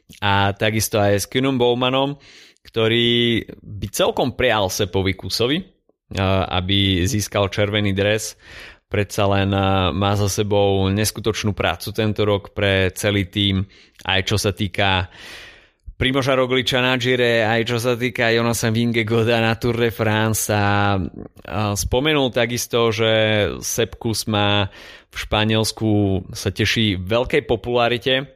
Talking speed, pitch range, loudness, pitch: 125 wpm, 100-115 Hz, -19 LUFS, 105 Hz